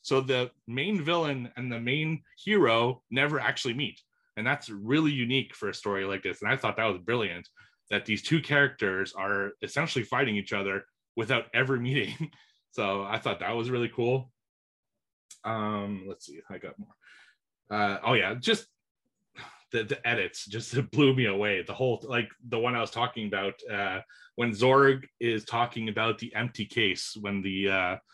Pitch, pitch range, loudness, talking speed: 120 Hz, 105-135 Hz, -29 LUFS, 180 wpm